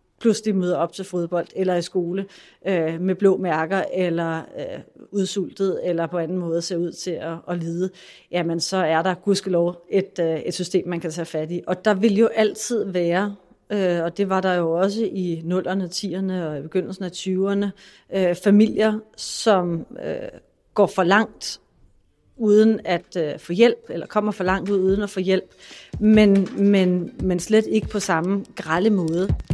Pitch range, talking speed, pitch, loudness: 175-200 Hz, 185 wpm, 185 Hz, -22 LUFS